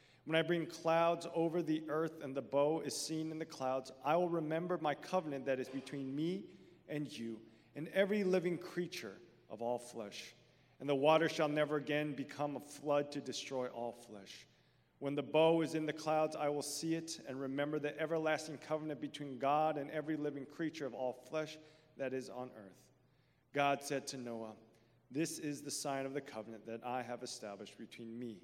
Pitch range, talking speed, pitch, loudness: 130-155 Hz, 195 wpm, 145 Hz, -39 LUFS